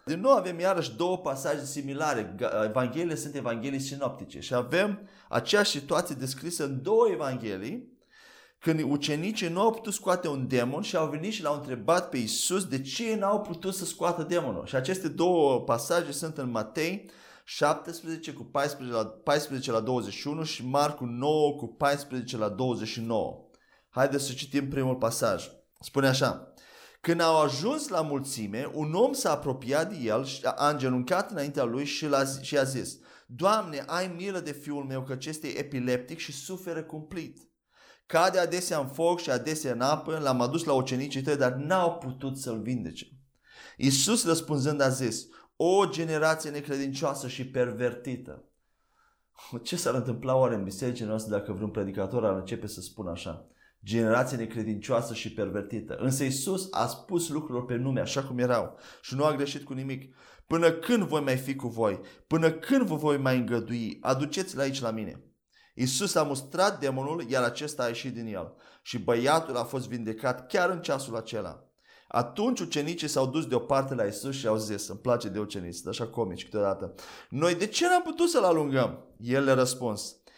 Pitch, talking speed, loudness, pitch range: 140 Hz, 170 wpm, -29 LUFS, 125-165 Hz